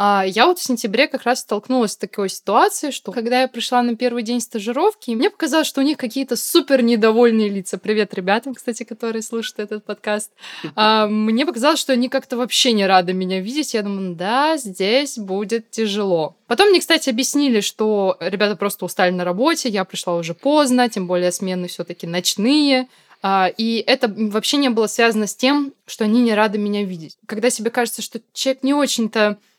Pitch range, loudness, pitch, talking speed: 205-255 Hz, -18 LUFS, 225 Hz, 190 wpm